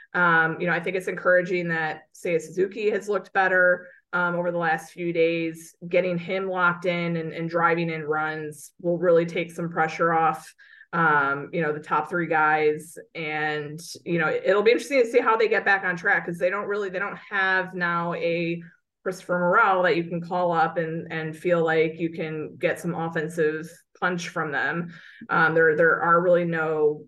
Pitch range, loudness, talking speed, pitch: 160-180 Hz, -24 LUFS, 195 wpm, 170 Hz